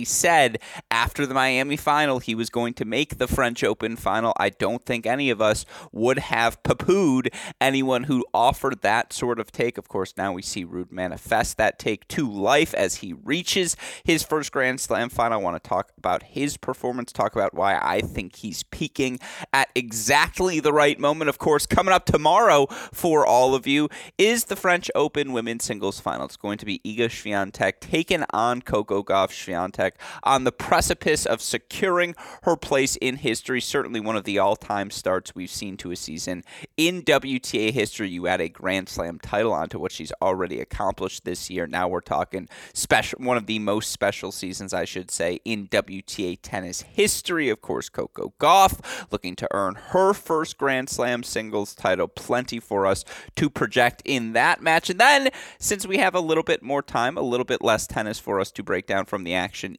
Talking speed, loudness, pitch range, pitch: 195 wpm, -23 LUFS, 105-150 Hz, 125 Hz